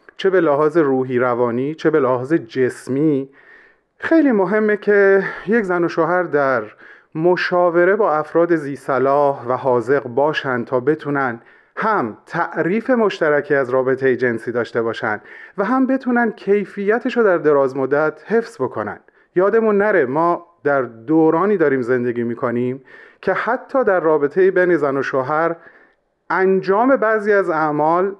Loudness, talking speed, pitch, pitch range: -17 LUFS, 135 wpm, 160 Hz, 135-200 Hz